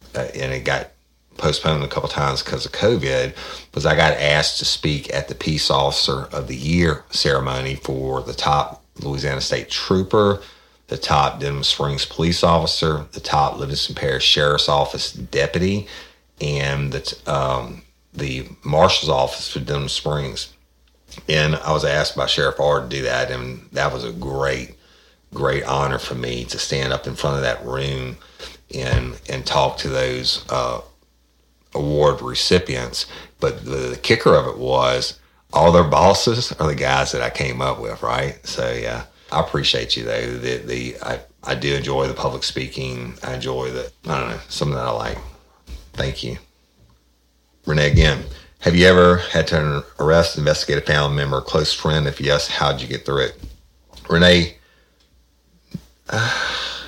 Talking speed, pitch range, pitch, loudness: 170 wpm, 65-75 Hz, 70 Hz, -19 LUFS